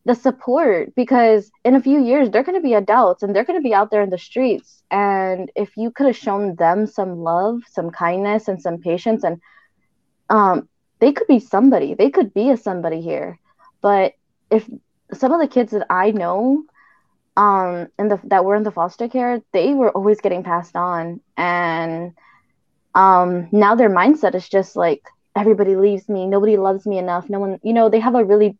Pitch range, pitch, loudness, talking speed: 185-235 Hz, 205 Hz, -17 LUFS, 195 wpm